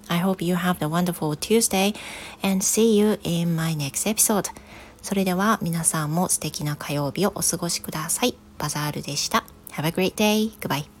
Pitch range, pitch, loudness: 160-200 Hz, 175 Hz, -23 LUFS